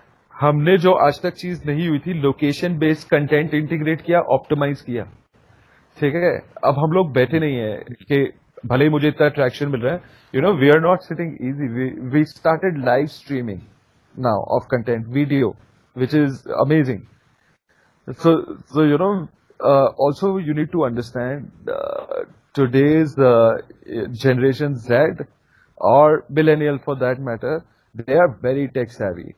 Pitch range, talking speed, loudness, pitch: 130-155 Hz, 145 wpm, -19 LUFS, 145 Hz